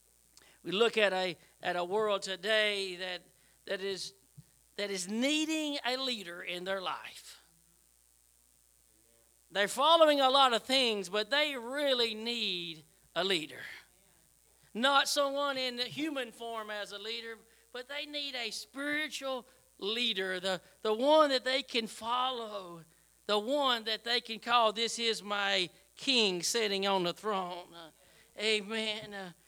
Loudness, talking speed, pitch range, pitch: -31 LUFS, 140 wpm, 190-250 Hz, 215 Hz